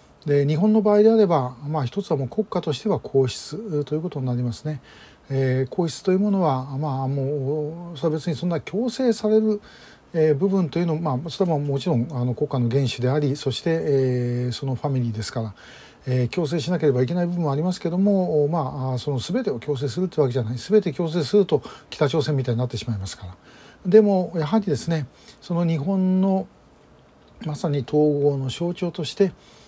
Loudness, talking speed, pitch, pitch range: -23 LUFS, 395 characters per minute, 150 Hz, 130-175 Hz